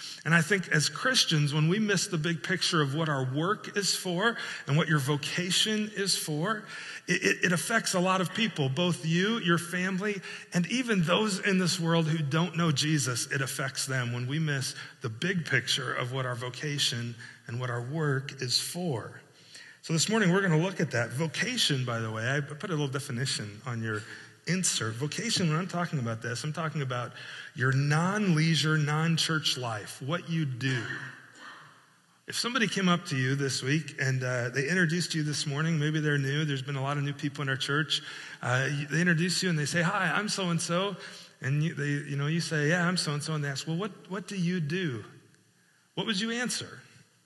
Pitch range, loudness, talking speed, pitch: 140-180 Hz, -29 LUFS, 210 wpm, 155 Hz